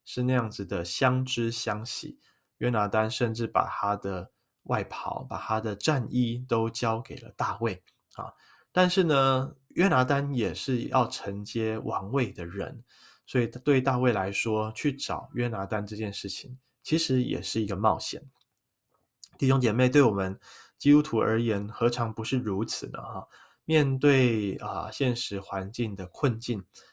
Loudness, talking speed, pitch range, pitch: -28 LUFS, 225 characters per minute, 110-130 Hz, 120 Hz